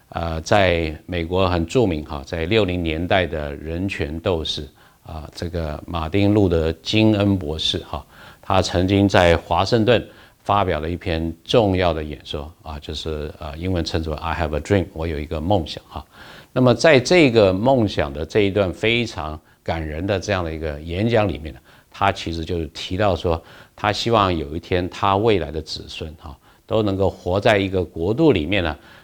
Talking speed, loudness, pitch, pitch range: 310 characters per minute, -20 LUFS, 85 Hz, 80-100 Hz